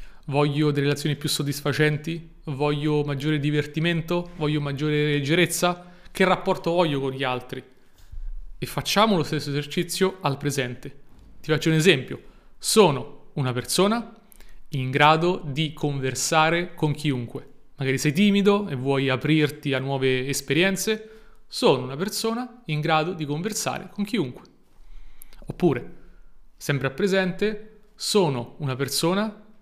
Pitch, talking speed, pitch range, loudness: 150 Hz, 125 wpm, 140-180 Hz, -24 LUFS